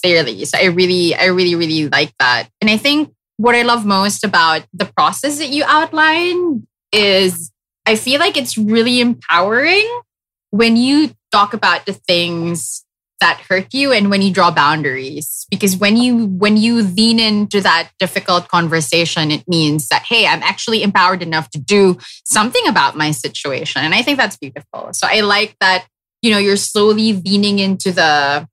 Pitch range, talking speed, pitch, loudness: 175-230 Hz, 175 wpm, 200 Hz, -13 LUFS